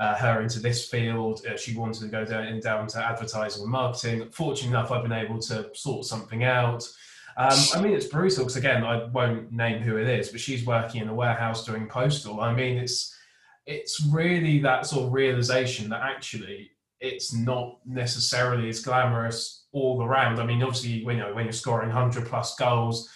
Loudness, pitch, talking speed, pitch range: -26 LUFS, 120 Hz, 195 wpm, 115-130 Hz